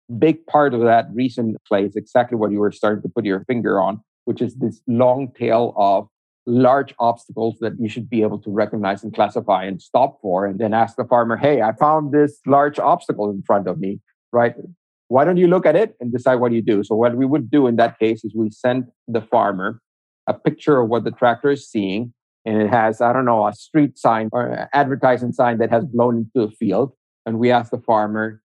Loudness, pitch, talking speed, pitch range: -19 LUFS, 120 Hz, 230 wpm, 110-130 Hz